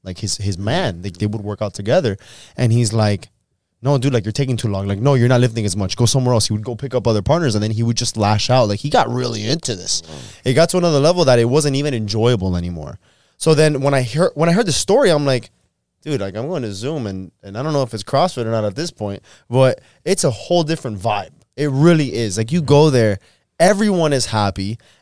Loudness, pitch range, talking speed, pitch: -17 LUFS, 105-145 Hz, 260 wpm, 120 Hz